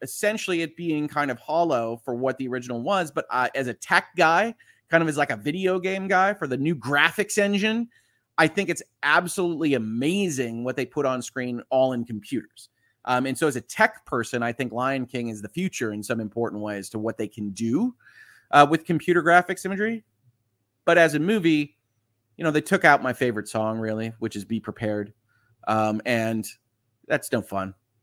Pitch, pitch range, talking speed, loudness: 130 Hz, 115-170 Hz, 200 wpm, -24 LUFS